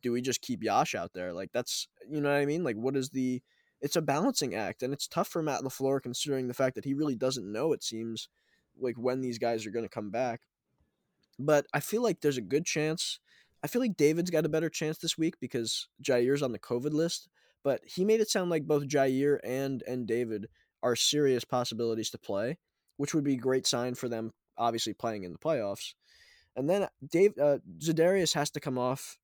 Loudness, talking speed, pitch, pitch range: -31 LUFS, 225 wpm, 135 Hz, 120-155 Hz